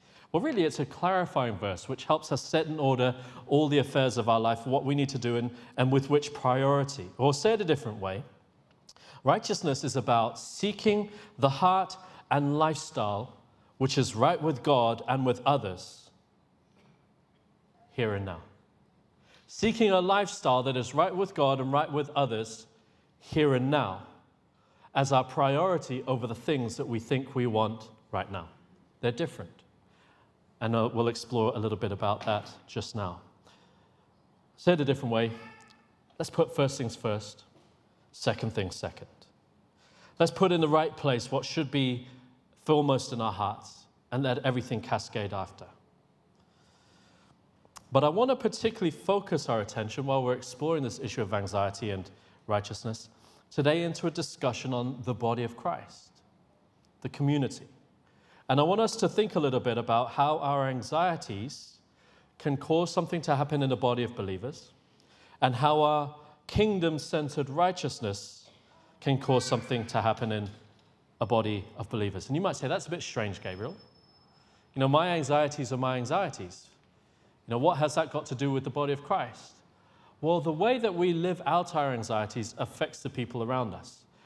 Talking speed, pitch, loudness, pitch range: 165 wpm, 130 Hz, -29 LUFS, 115-150 Hz